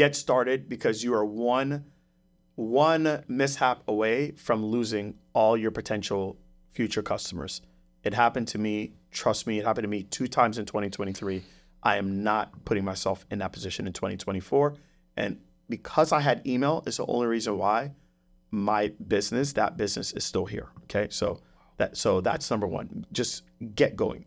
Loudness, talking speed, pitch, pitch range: -28 LUFS, 165 wpm, 110 Hz, 95-130 Hz